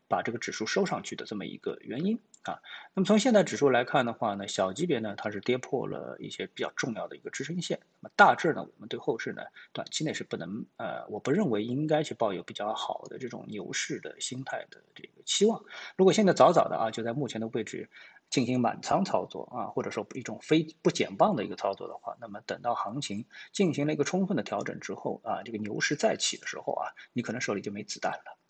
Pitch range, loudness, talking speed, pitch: 125-195 Hz, -30 LUFS, 355 characters per minute, 155 Hz